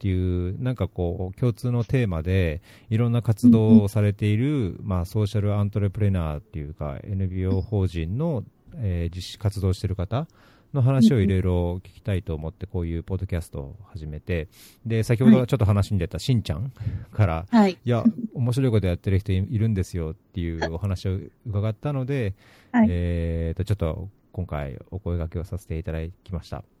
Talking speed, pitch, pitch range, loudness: 350 characters per minute, 100 Hz, 90-110 Hz, -24 LUFS